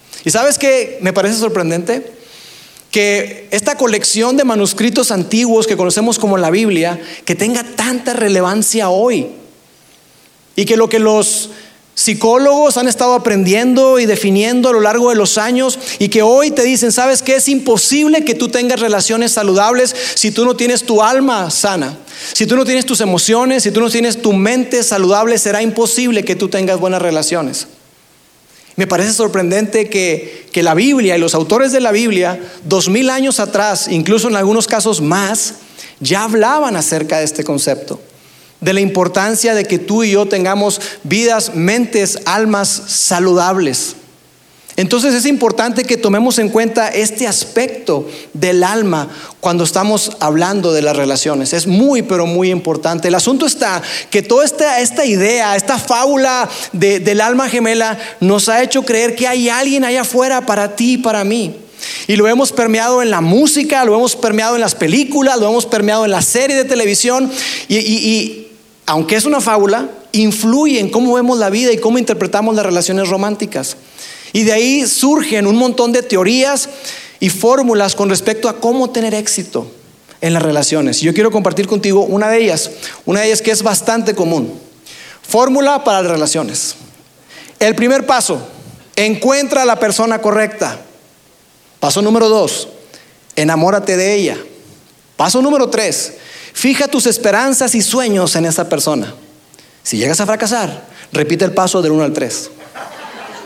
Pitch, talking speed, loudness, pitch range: 220 Hz, 165 wpm, -12 LUFS, 195-245 Hz